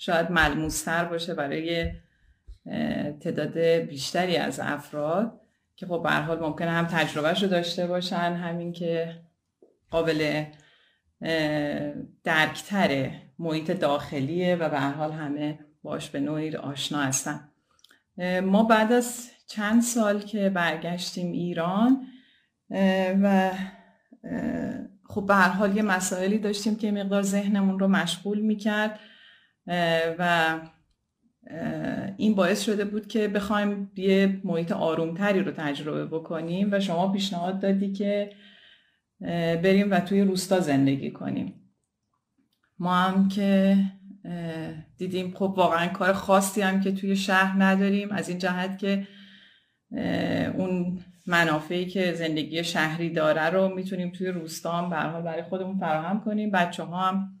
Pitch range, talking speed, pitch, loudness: 165-200 Hz, 115 wpm, 180 Hz, -26 LUFS